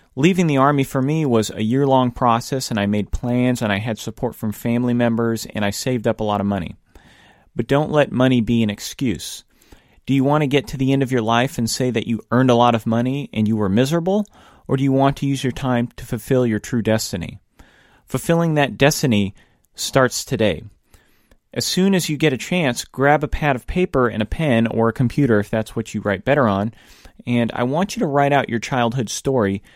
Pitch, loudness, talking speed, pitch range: 125 Hz, -19 LUFS, 230 wpm, 110-140 Hz